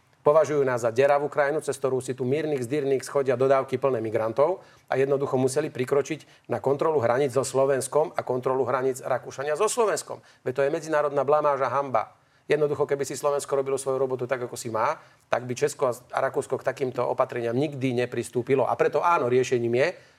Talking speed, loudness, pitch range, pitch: 185 wpm, -25 LUFS, 130-145 Hz, 135 Hz